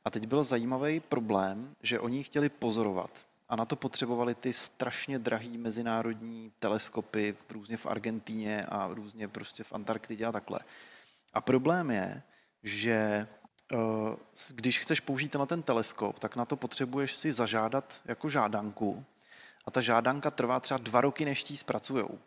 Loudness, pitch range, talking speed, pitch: -32 LUFS, 110-135 Hz, 150 wpm, 115 Hz